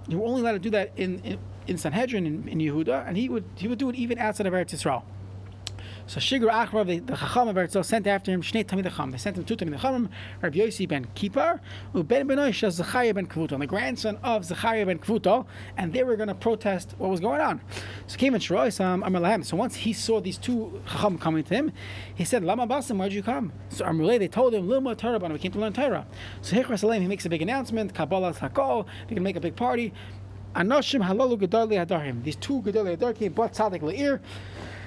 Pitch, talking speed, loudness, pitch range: 200 Hz, 220 wpm, -26 LUFS, 160-230 Hz